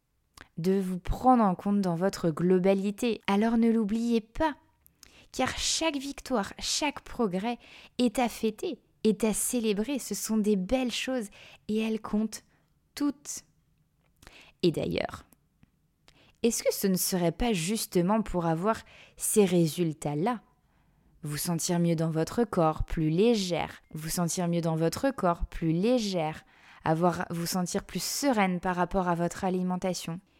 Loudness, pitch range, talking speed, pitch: -29 LUFS, 175-230 Hz, 140 wpm, 195 Hz